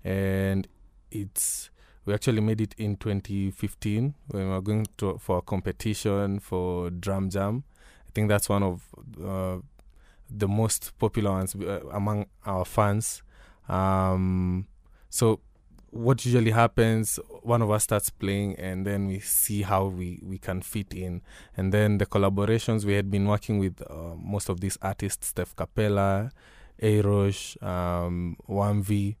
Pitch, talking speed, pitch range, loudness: 100 Hz, 150 wpm, 95-105 Hz, -27 LUFS